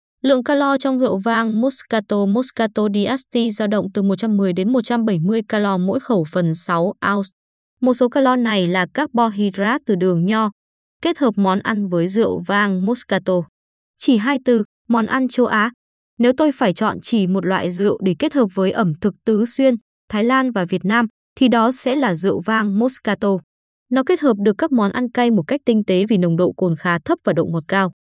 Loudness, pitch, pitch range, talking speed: -18 LUFS, 220 Hz, 195-250 Hz, 205 wpm